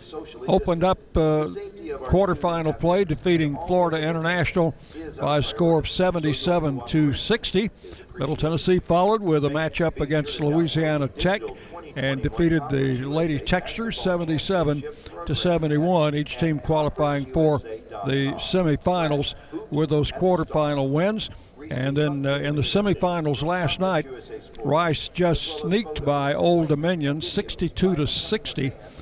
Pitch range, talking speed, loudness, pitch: 145-180 Hz, 125 wpm, -23 LUFS, 155 Hz